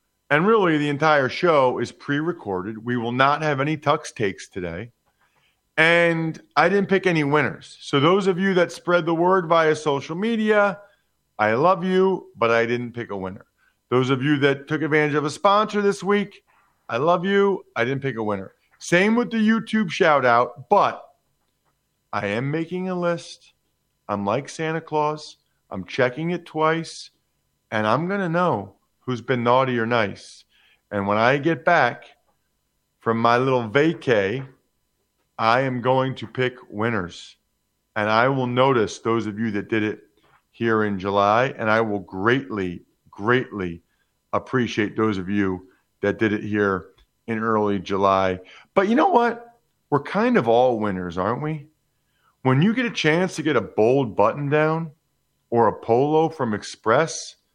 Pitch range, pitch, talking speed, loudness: 110-170 Hz, 140 Hz, 170 wpm, -21 LUFS